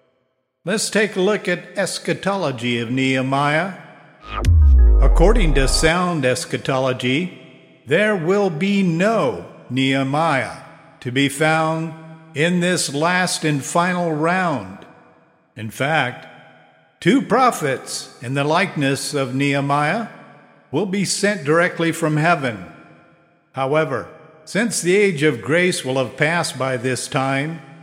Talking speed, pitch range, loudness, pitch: 115 wpm, 130-175 Hz, -19 LUFS, 155 Hz